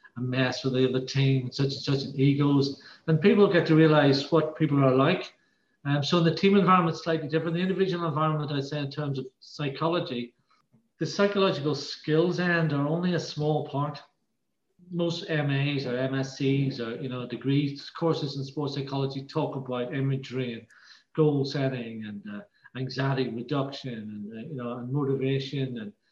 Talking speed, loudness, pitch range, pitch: 175 wpm, -27 LUFS, 130-160 Hz, 140 Hz